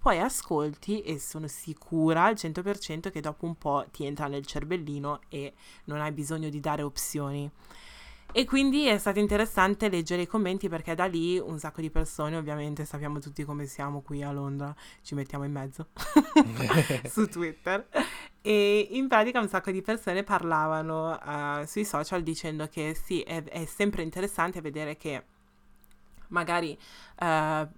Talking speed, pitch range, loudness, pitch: 155 wpm, 150-190 Hz, -29 LUFS, 160 Hz